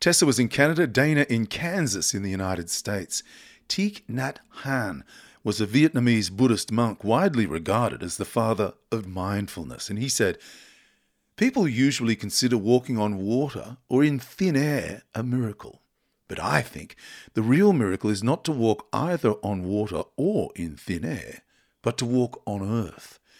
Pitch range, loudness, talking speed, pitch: 105-135 Hz, -25 LUFS, 160 wpm, 115 Hz